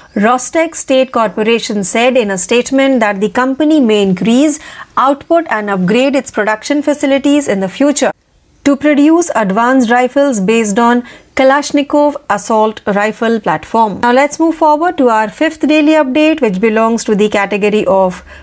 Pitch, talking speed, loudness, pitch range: 245 Hz, 150 wpm, -11 LUFS, 215-290 Hz